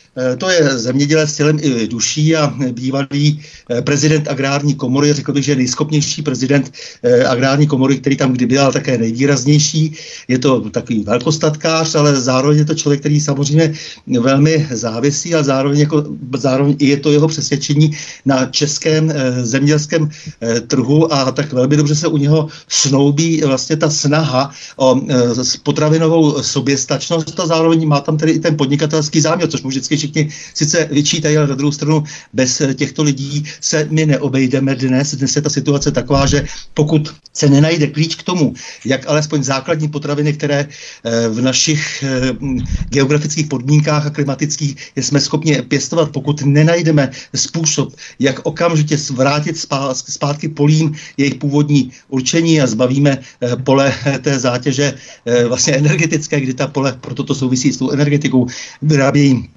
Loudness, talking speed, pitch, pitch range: -14 LUFS, 145 wpm, 145 Hz, 135-155 Hz